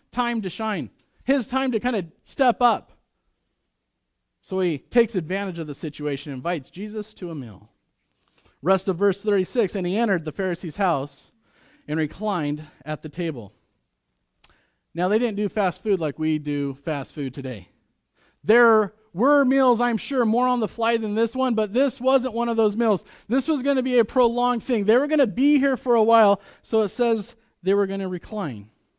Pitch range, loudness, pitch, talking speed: 165-240 Hz, -23 LUFS, 210 Hz, 195 wpm